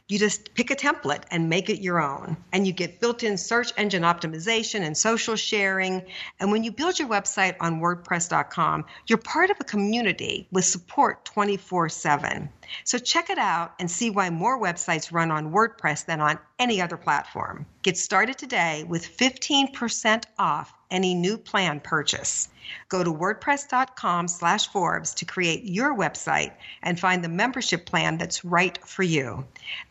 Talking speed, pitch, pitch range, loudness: 165 wpm, 190 Hz, 170-225 Hz, -24 LUFS